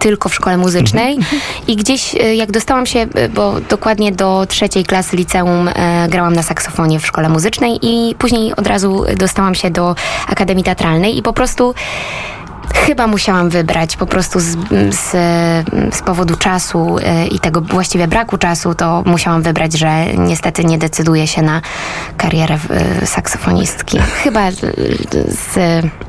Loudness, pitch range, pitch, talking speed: -13 LUFS, 165-205 Hz, 180 Hz, 150 wpm